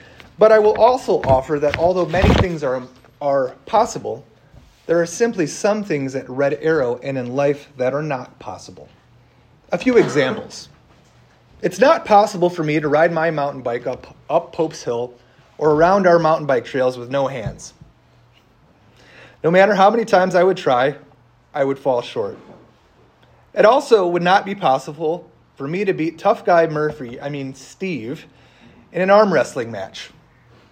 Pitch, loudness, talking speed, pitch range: 155 Hz, -18 LUFS, 170 wpm, 135-180 Hz